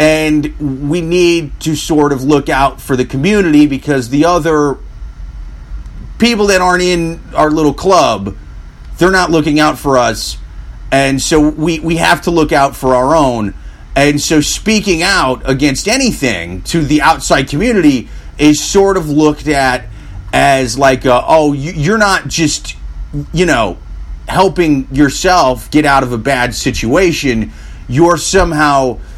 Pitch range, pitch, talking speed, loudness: 125-165 Hz, 145 Hz, 150 wpm, -11 LUFS